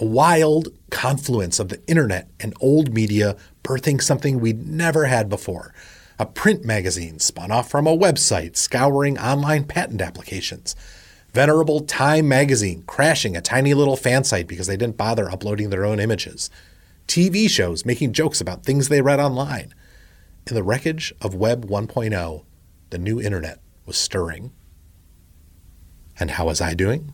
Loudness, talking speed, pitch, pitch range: -20 LUFS, 155 wpm, 110 Hz, 90-140 Hz